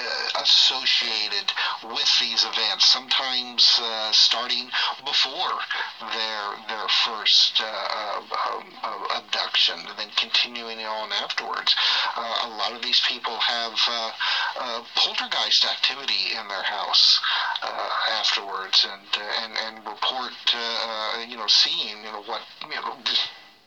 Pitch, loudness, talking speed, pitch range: 115 Hz, -21 LUFS, 125 wpm, 110-120 Hz